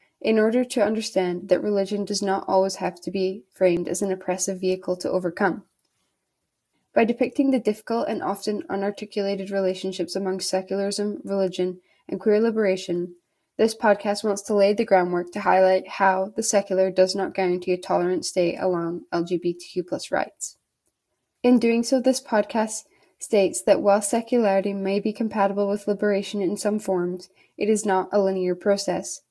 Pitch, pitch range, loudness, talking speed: 195 Hz, 185-210 Hz, -23 LUFS, 160 wpm